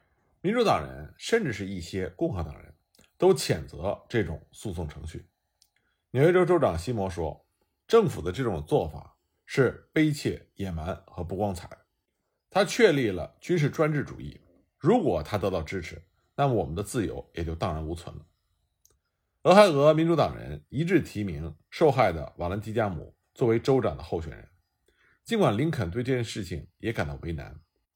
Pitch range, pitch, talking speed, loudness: 85-125 Hz, 95 Hz, 255 characters per minute, -27 LUFS